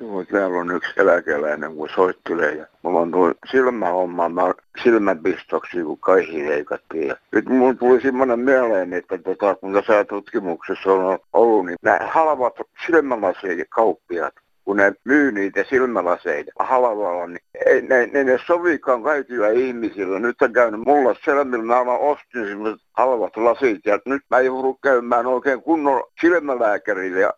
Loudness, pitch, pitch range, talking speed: -19 LUFS, 125 Hz, 100-140 Hz, 145 wpm